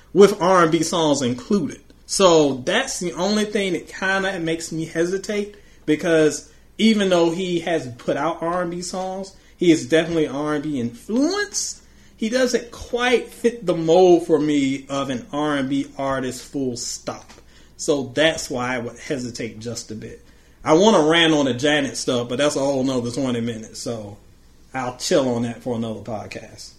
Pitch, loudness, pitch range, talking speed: 155 Hz, -20 LUFS, 125-180 Hz, 170 wpm